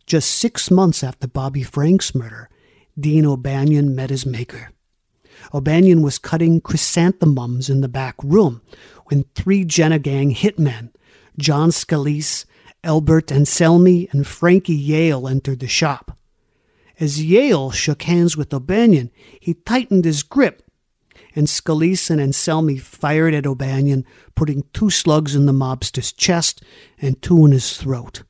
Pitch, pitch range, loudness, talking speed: 150 Hz, 135-165 Hz, -17 LUFS, 135 wpm